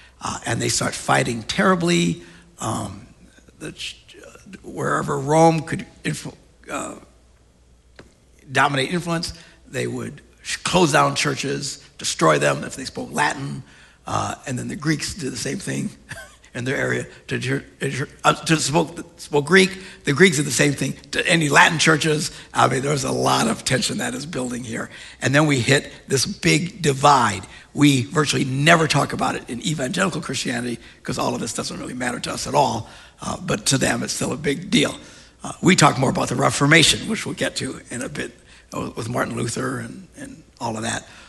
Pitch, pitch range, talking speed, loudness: 145 Hz, 115-160 Hz, 180 wpm, -20 LUFS